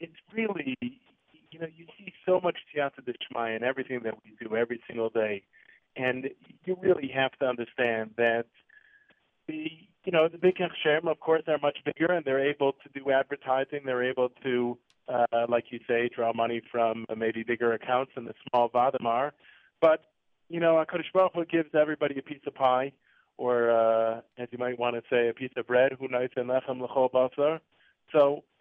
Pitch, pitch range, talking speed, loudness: 130 Hz, 120-160 Hz, 180 wpm, -28 LUFS